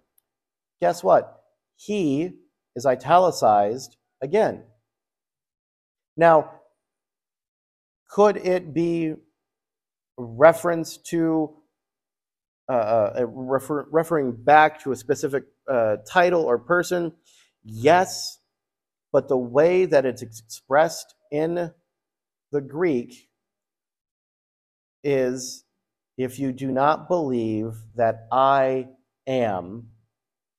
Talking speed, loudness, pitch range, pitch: 85 wpm, -22 LUFS, 125-165 Hz, 140 Hz